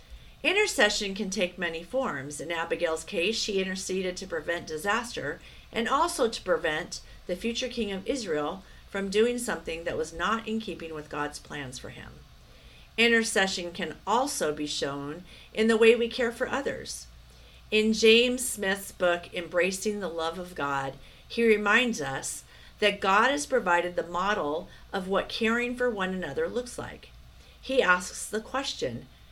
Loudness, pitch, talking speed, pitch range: -28 LUFS, 195 Hz, 160 wpm, 170-230 Hz